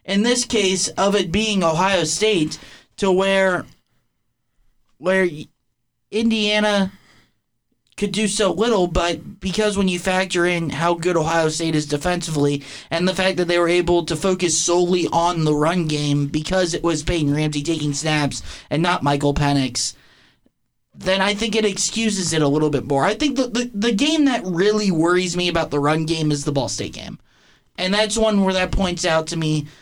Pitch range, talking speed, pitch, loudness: 155-195 Hz, 185 wpm, 175 Hz, -19 LUFS